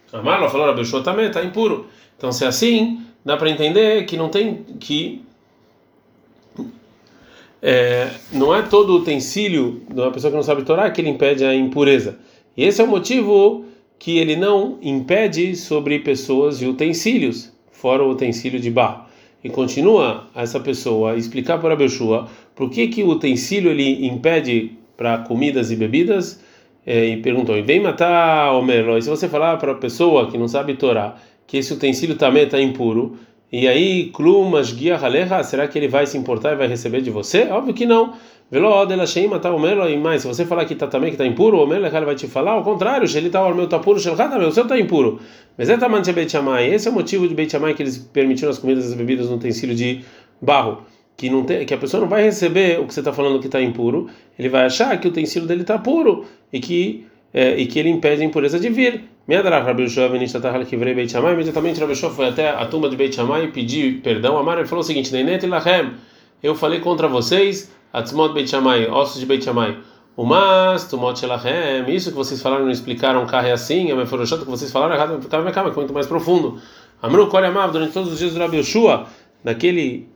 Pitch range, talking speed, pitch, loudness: 130-180 Hz, 215 wpm, 145 Hz, -18 LUFS